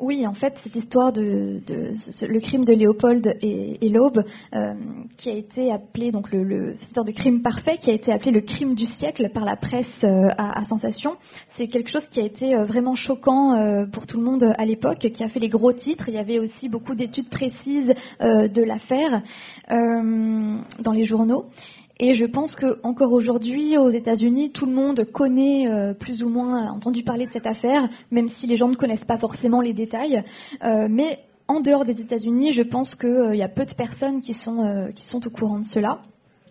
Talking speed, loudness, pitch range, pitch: 215 wpm, -22 LUFS, 220-255 Hz, 235 Hz